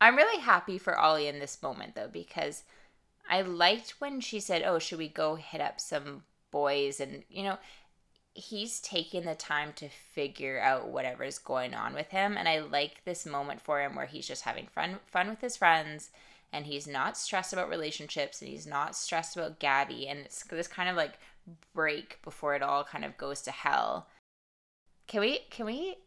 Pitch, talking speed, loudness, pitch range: 160 Hz, 200 wpm, -32 LUFS, 145-185 Hz